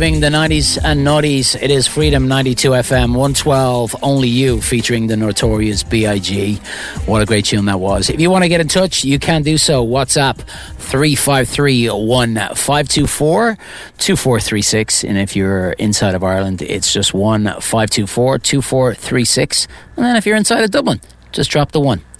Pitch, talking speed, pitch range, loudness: 125 Hz, 155 wpm, 105-145 Hz, -13 LUFS